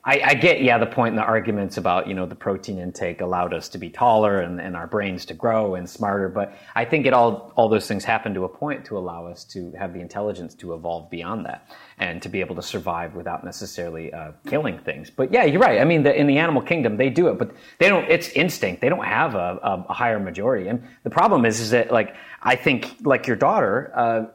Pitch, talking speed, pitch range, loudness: 100 Hz, 250 wpm, 90-115 Hz, -21 LUFS